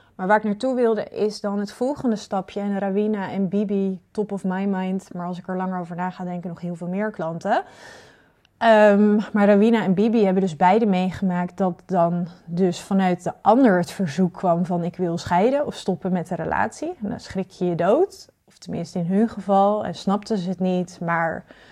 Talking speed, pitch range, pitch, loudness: 210 wpm, 180-210 Hz, 190 Hz, -22 LUFS